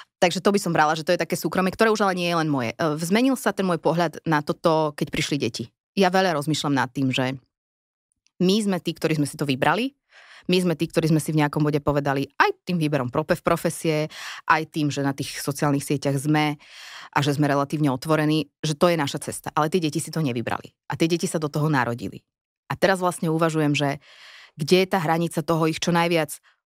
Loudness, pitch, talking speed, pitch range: -23 LUFS, 155 Hz, 225 wpm, 145-175 Hz